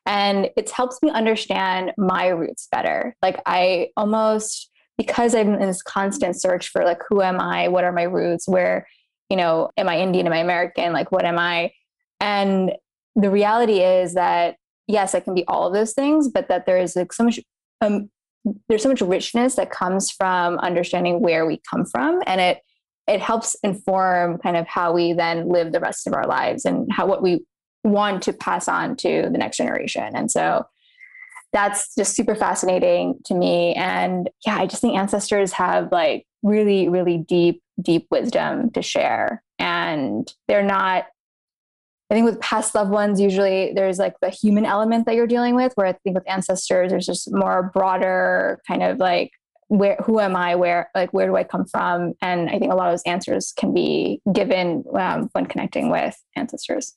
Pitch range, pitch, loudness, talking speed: 180-220 Hz, 195 Hz, -20 LUFS, 190 wpm